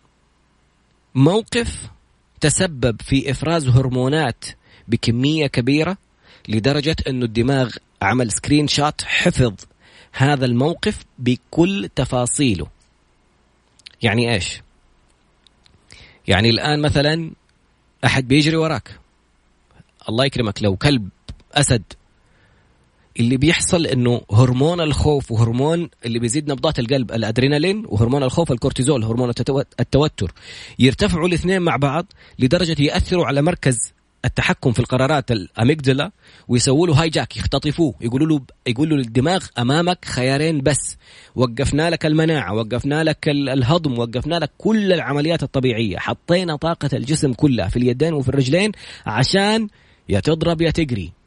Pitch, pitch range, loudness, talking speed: 135 Hz, 115-155 Hz, -18 LUFS, 110 wpm